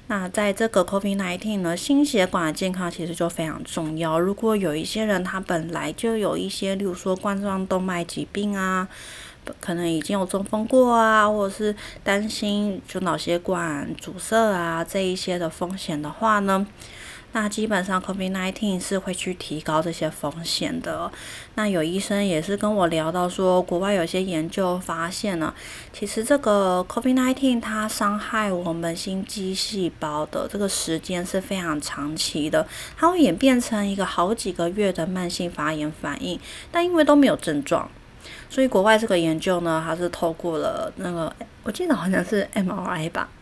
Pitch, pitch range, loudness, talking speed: 190 Hz, 170-210 Hz, -24 LUFS, 270 characters per minute